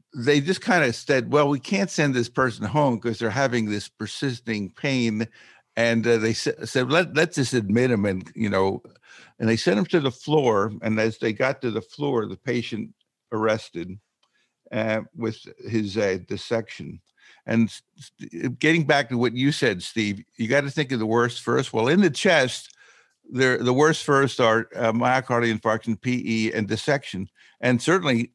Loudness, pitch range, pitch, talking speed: -23 LUFS, 110-140 Hz, 120 Hz, 180 wpm